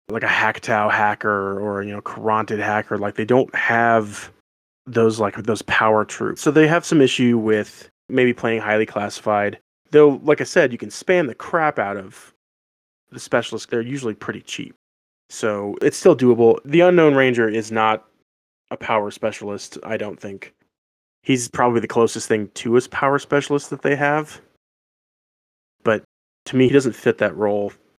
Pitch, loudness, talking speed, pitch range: 115 Hz, -19 LUFS, 170 wpm, 105-135 Hz